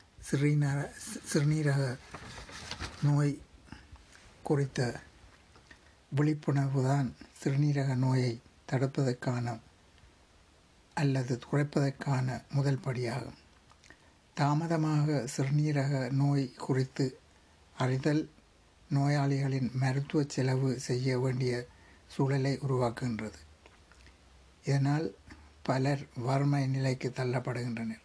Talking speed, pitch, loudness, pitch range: 60 wpm, 130 Hz, -32 LUFS, 120-140 Hz